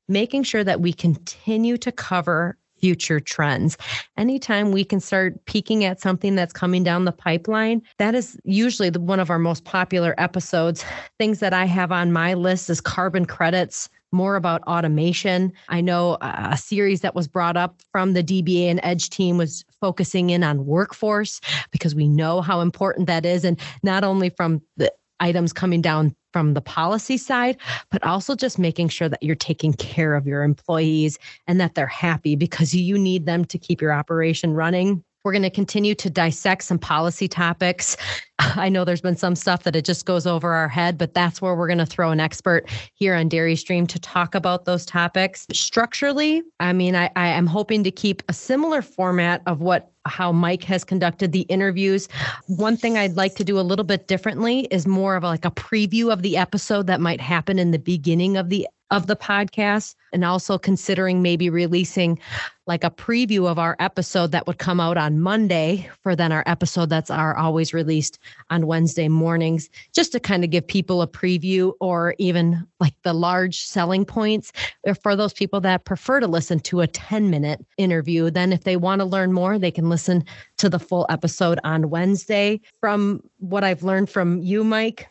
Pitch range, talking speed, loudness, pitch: 170-195 Hz, 195 wpm, -21 LUFS, 180 Hz